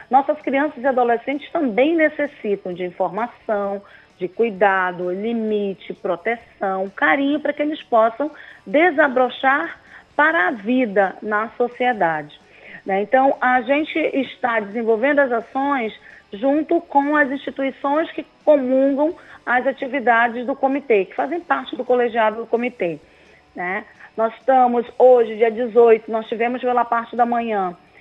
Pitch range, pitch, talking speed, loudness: 220-280 Hz, 245 Hz, 130 wpm, -19 LUFS